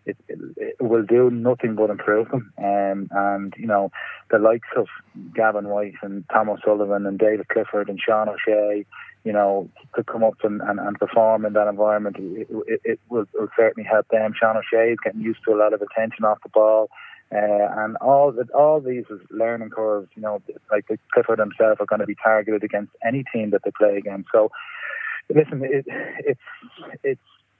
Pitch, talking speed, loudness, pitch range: 110 Hz, 200 wpm, -21 LUFS, 105-115 Hz